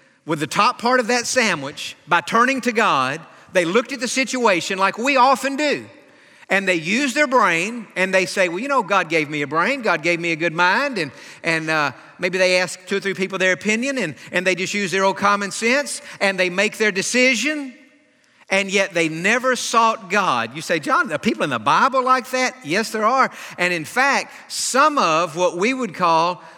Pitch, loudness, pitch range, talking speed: 200 Hz, -19 LUFS, 180-255 Hz, 215 wpm